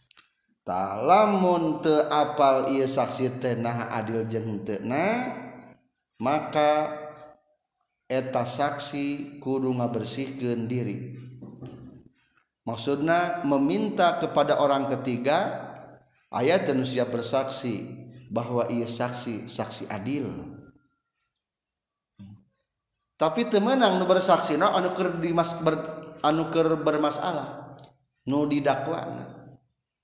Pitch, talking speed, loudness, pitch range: 140 Hz, 70 wpm, -25 LUFS, 120-155 Hz